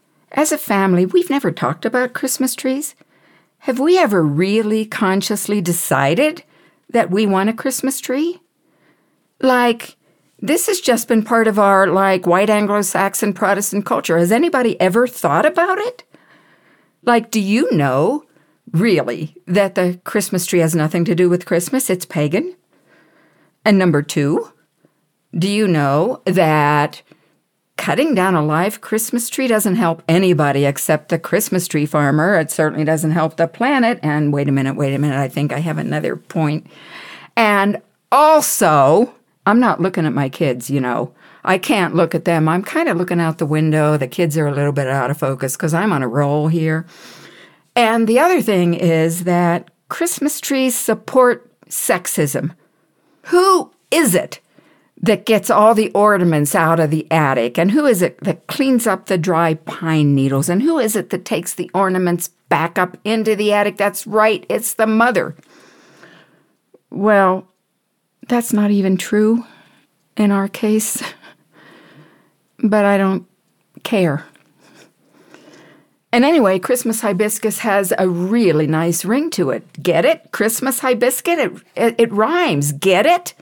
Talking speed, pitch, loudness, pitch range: 155 wpm, 195 Hz, -16 LUFS, 165-230 Hz